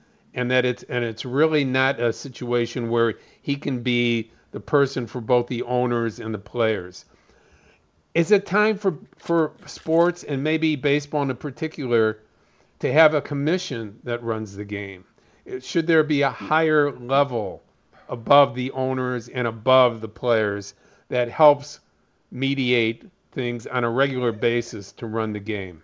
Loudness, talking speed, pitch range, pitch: -22 LUFS, 155 wpm, 115-145 Hz, 125 Hz